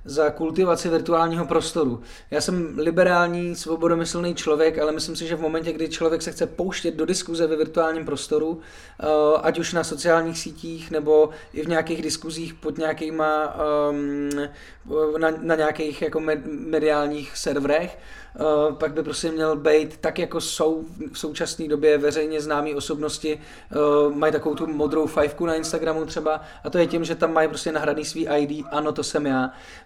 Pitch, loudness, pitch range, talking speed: 155 Hz, -23 LUFS, 150-165 Hz, 170 wpm